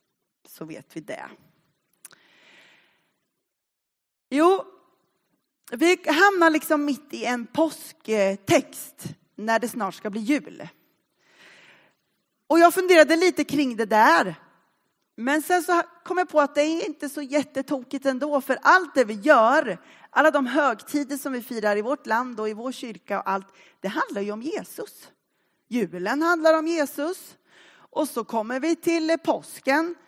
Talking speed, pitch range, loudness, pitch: 145 wpm, 235-325 Hz, -23 LUFS, 290 Hz